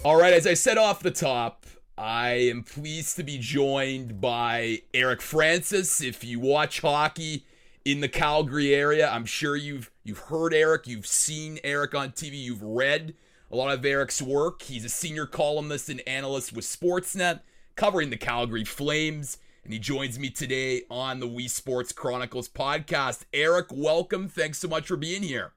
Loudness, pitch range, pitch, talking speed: -26 LUFS, 125-155 Hz, 140 Hz, 175 wpm